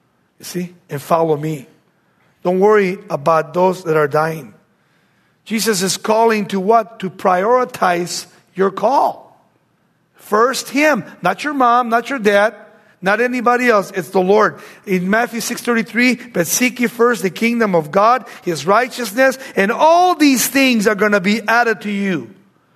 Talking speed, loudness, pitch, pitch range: 155 wpm, -15 LUFS, 210 Hz, 180-235 Hz